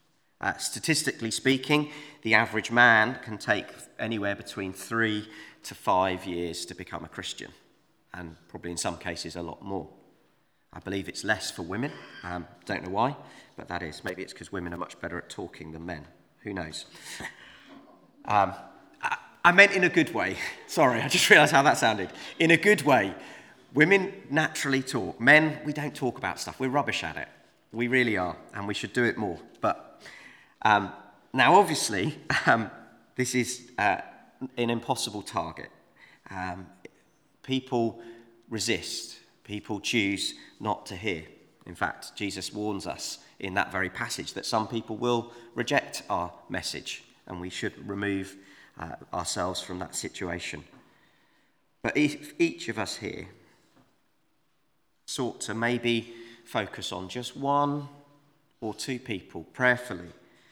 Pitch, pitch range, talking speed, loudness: 115 Hz, 95-130 Hz, 155 wpm, -27 LUFS